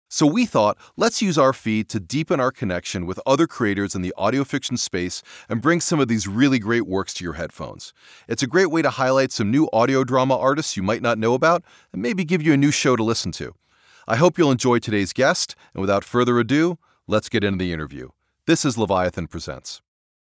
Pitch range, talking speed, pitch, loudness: 100-140 Hz, 225 wpm, 120 Hz, -21 LUFS